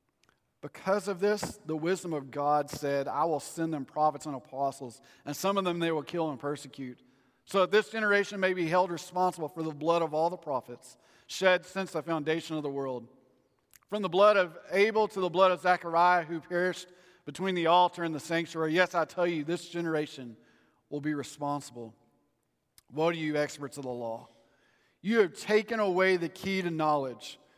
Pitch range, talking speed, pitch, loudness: 145-185 Hz, 190 wpm, 165 Hz, -30 LUFS